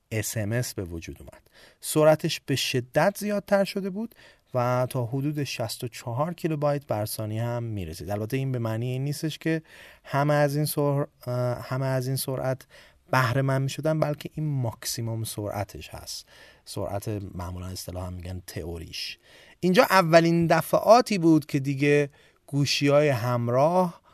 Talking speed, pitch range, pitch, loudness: 140 wpm, 110-155 Hz, 135 Hz, -26 LUFS